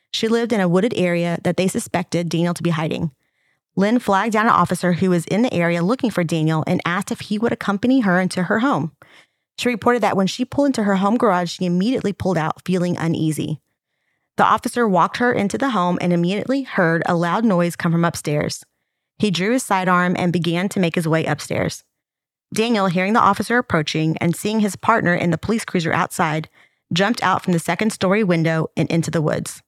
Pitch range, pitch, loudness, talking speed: 170-215 Hz, 180 Hz, -19 LUFS, 210 wpm